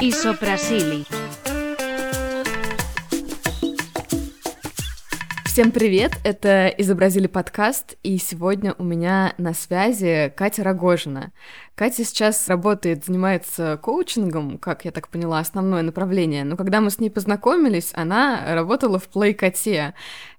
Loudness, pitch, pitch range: -21 LUFS, 190 Hz, 170-225 Hz